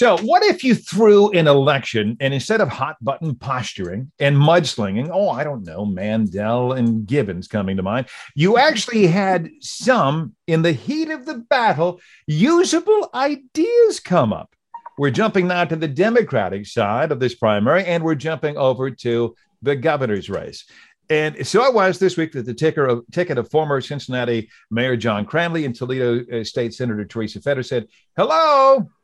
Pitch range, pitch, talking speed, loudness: 120-190 Hz, 145 Hz, 170 wpm, -19 LUFS